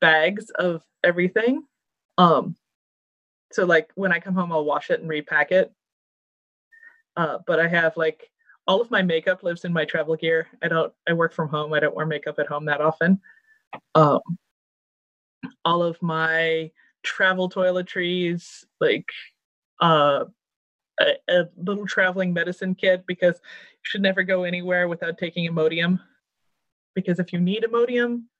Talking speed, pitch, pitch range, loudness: 150 wpm, 180 Hz, 165-190 Hz, -22 LUFS